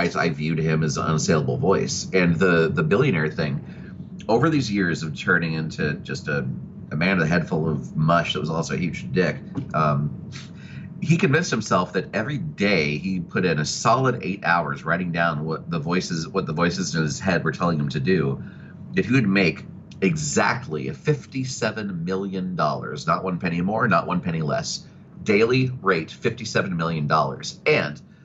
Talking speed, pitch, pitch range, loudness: 185 wpm, 85 Hz, 80-105 Hz, -23 LUFS